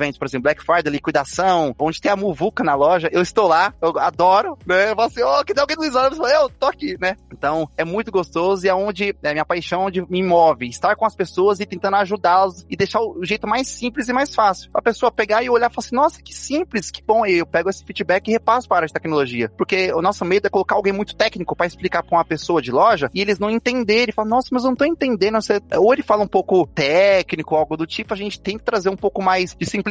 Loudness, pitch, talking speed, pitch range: -18 LUFS, 195 Hz, 270 wpm, 175-225 Hz